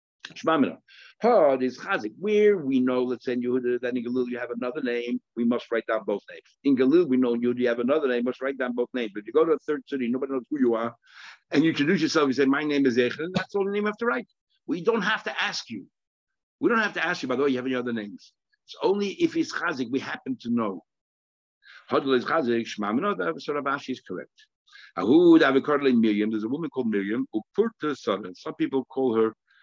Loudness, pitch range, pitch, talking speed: -25 LUFS, 120-195 Hz, 130 Hz, 250 wpm